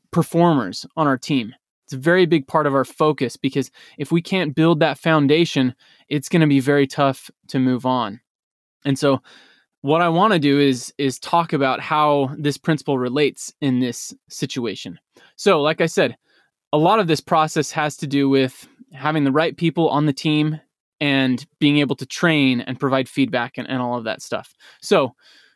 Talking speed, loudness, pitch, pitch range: 190 wpm, -19 LUFS, 145 Hz, 130-160 Hz